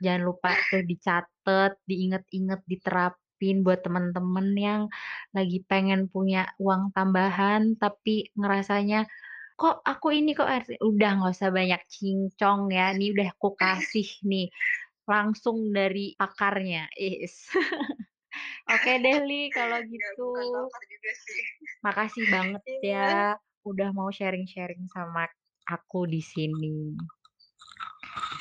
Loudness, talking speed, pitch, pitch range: -27 LUFS, 105 wpm, 195 Hz, 185-215 Hz